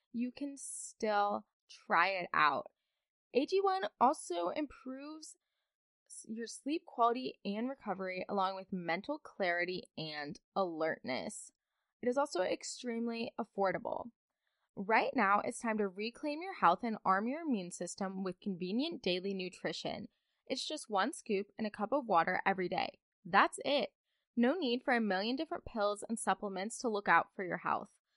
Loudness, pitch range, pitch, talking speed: -36 LUFS, 190-275 Hz, 225 Hz, 150 wpm